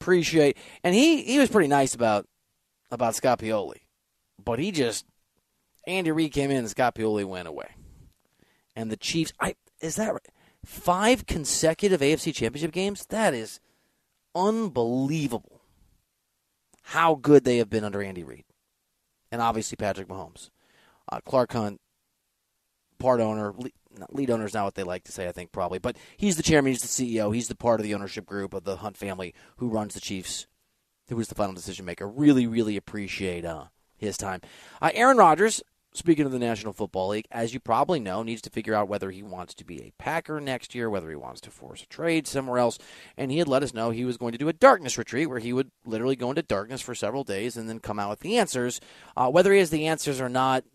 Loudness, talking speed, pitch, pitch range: -26 LUFS, 205 wpm, 120 Hz, 105-155 Hz